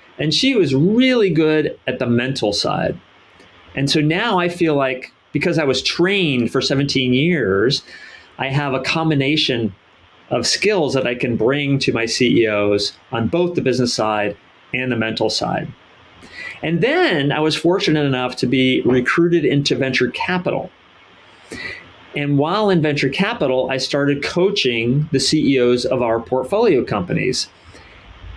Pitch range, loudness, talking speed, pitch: 120-155 Hz, -17 LUFS, 150 wpm, 135 Hz